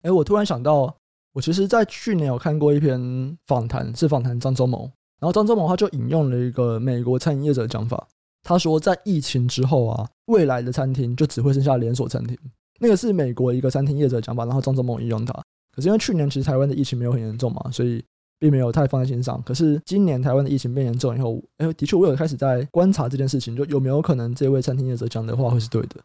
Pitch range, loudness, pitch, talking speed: 125-155 Hz, -21 LUFS, 135 Hz, 380 characters per minute